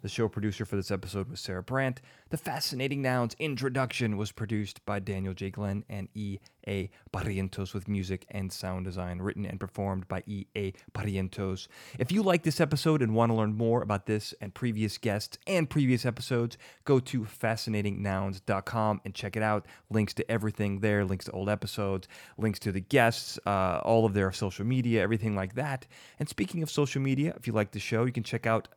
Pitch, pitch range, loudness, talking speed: 105 Hz, 100-120 Hz, -31 LUFS, 200 wpm